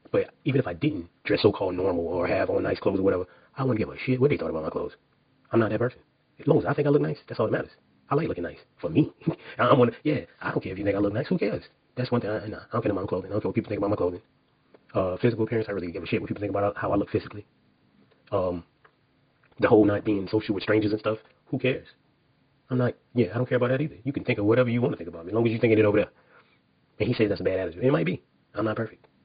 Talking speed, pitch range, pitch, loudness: 315 wpm, 105-125 Hz, 110 Hz, -26 LUFS